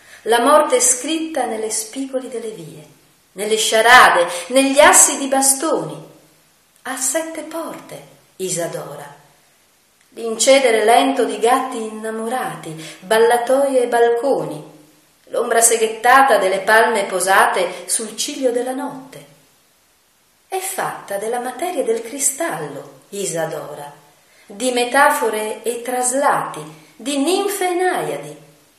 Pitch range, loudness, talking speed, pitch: 195-270 Hz, -16 LUFS, 100 wpm, 235 Hz